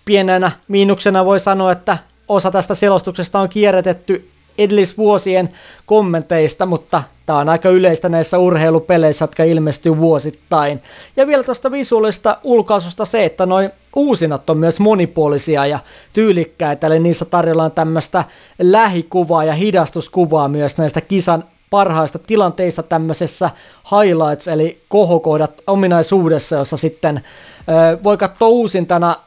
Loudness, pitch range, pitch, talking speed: -14 LUFS, 160-200 Hz, 175 Hz, 120 wpm